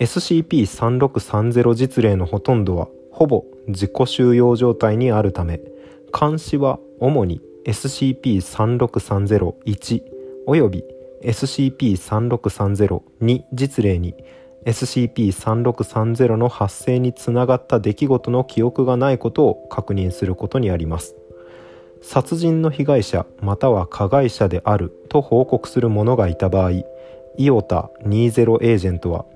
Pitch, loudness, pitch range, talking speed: 120 Hz, -19 LUFS, 100-130 Hz, 225 characters per minute